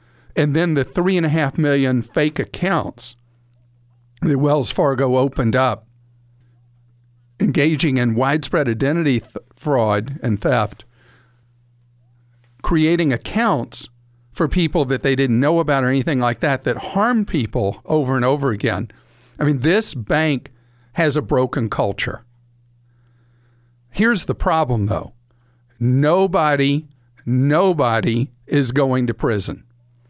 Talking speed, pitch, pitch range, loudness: 120 wpm, 125 Hz, 120-150 Hz, -19 LUFS